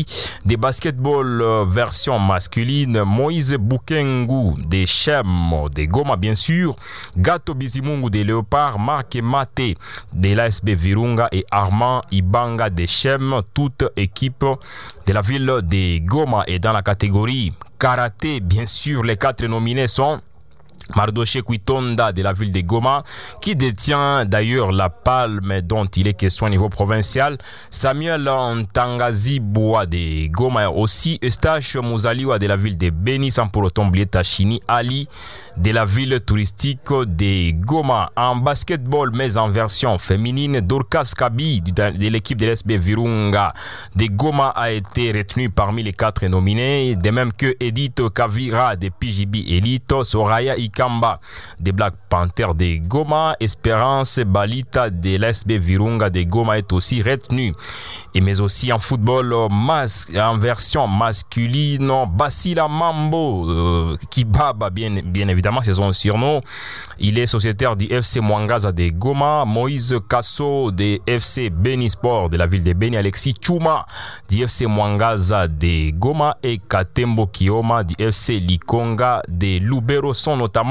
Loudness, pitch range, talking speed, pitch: -18 LUFS, 100-130 Hz, 140 wpm, 115 Hz